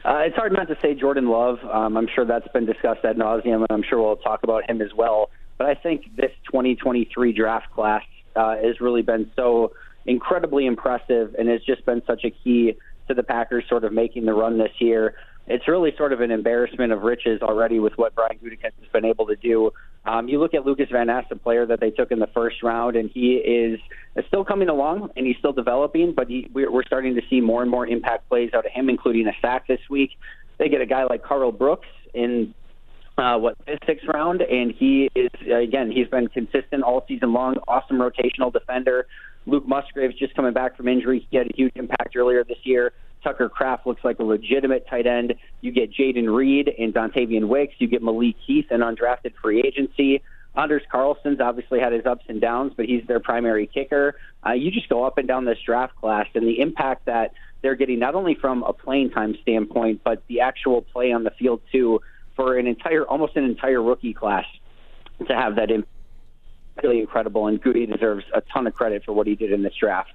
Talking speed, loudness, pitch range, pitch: 220 wpm, -22 LUFS, 115-130 Hz, 120 Hz